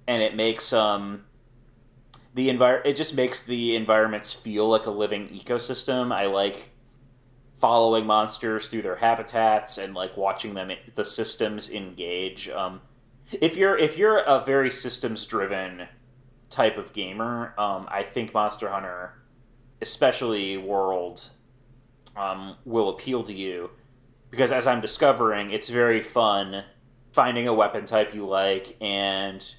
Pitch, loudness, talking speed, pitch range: 115 Hz, -25 LUFS, 140 wpm, 100-125 Hz